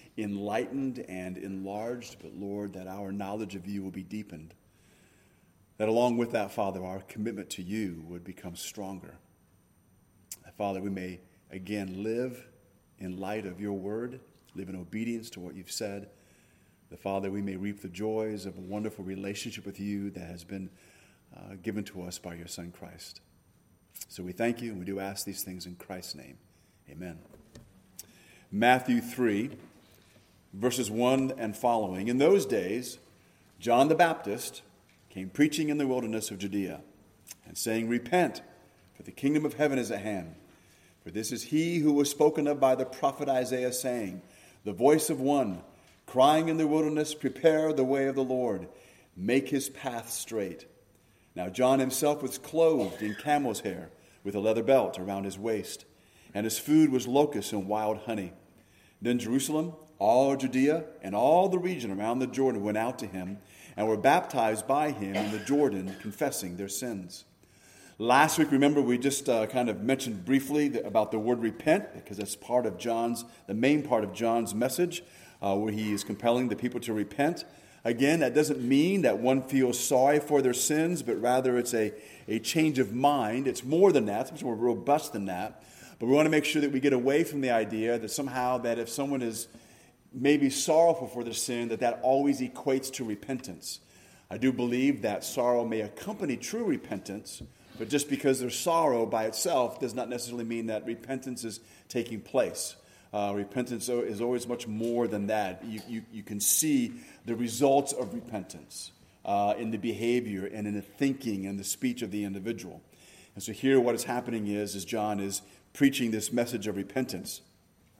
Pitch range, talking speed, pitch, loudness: 100-130 Hz, 180 wpm, 115 Hz, -29 LUFS